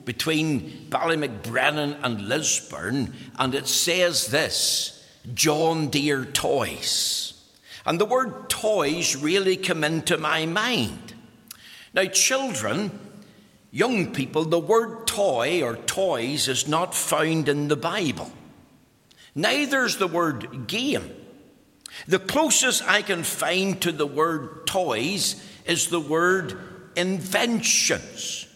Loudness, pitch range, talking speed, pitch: -23 LUFS, 150-195 Hz, 115 wpm, 165 Hz